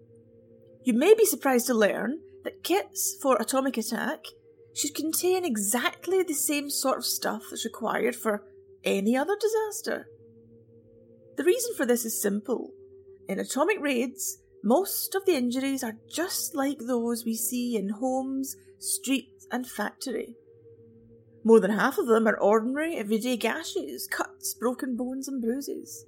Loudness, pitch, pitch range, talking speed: -27 LUFS, 265 Hz, 225-375 Hz, 145 wpm